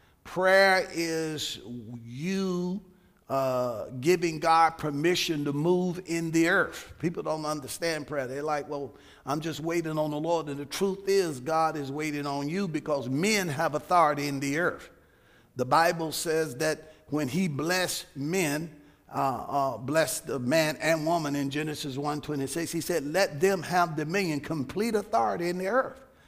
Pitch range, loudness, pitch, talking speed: 145-175 Hz, -28 LUFS, 160 Hz, 160 wpm